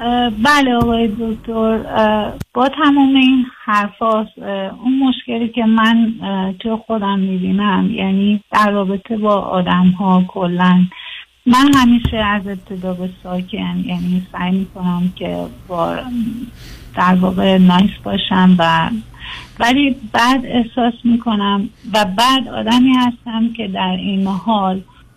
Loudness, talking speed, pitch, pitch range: -15 LUFS, 115 wpm, 210 Hz, 185-235 Hz